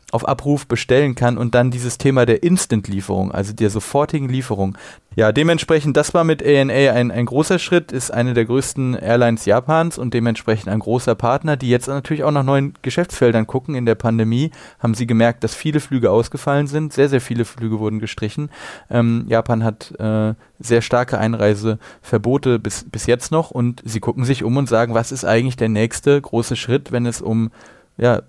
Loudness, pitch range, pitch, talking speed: -18 LUFS, 115-140 Hz, 120 Hz, 190 wpm